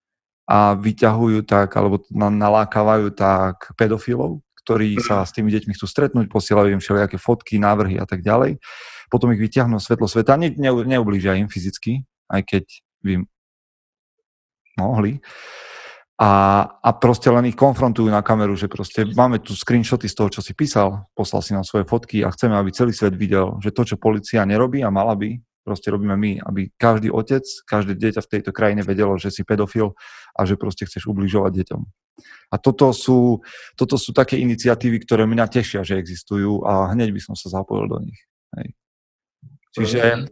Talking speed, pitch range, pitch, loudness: 170 wpm, 100-120 Hz, 105 Hz, -19 LUFS